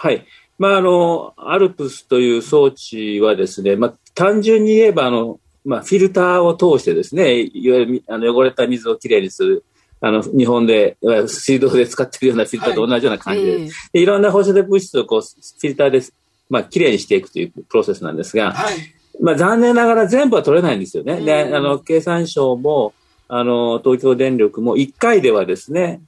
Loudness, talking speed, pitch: -15 LUFS, 390 characters per minute, 160 Hz